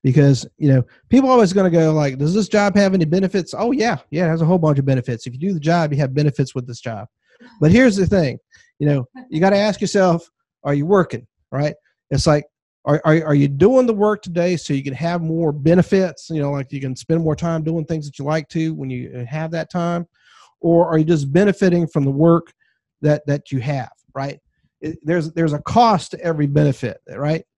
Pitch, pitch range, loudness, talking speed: 160 Hz, 145-180 Hz, -18 LUFS, 235 wpm